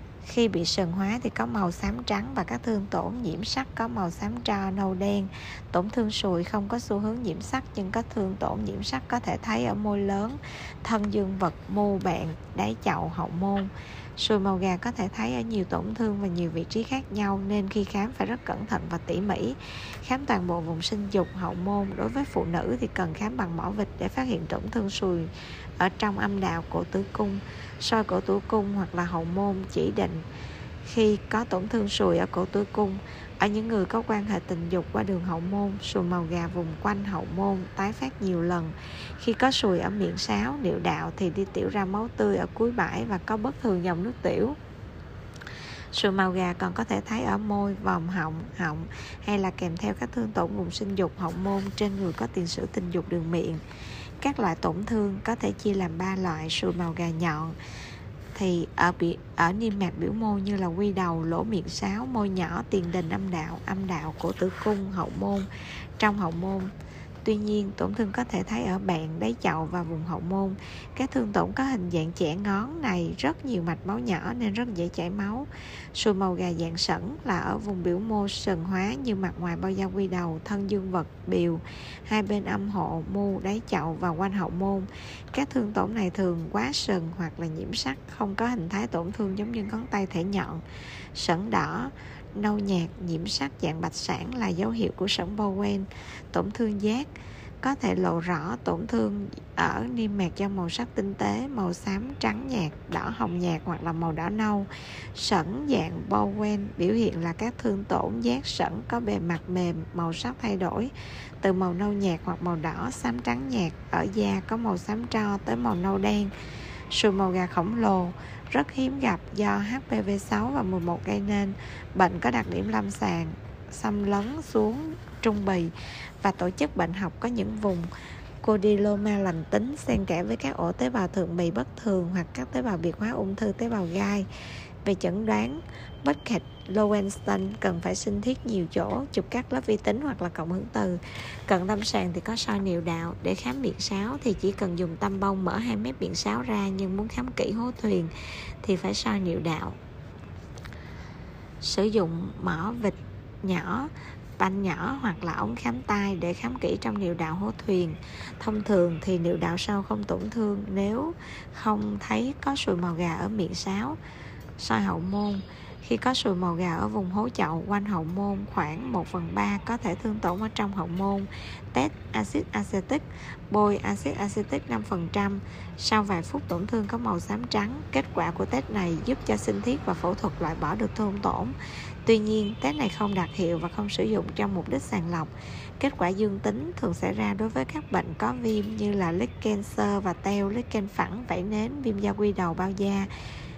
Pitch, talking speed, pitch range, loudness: 190 Hz, 210 wpm, 165-210 Hz, -28 LUFS